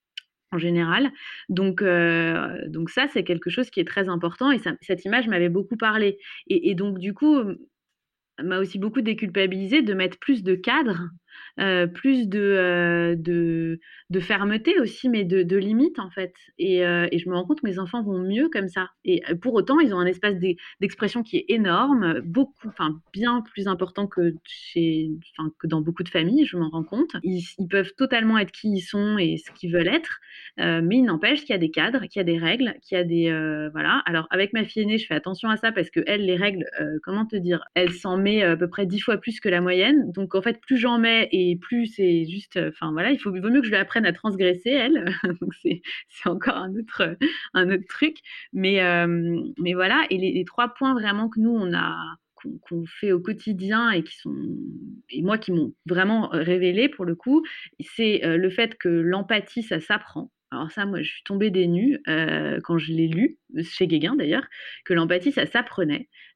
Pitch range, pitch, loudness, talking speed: 175-235 Hz, 195 Hz, -23 LUFS, 220 wpm